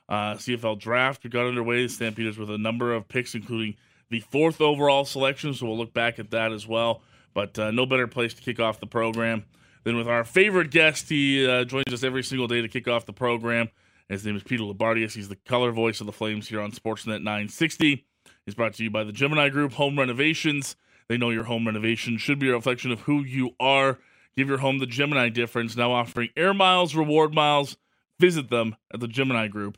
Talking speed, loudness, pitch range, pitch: 220 wpm, -24 LUFS, 110-135 Hz, 120 Hz